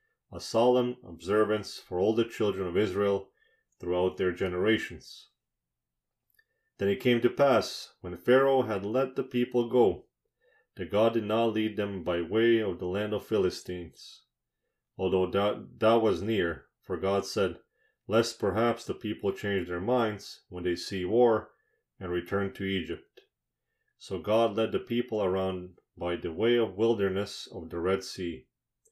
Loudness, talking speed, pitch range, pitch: -29 LUFS, 155 wpm, 90-115 Hz, 105 Hz